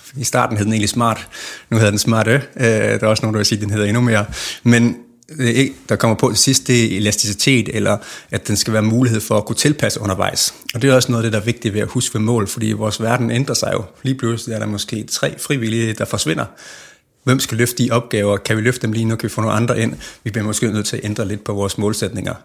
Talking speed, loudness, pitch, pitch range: 275 wpm, -17 LUFS, 115 Hz, 105-120 Hz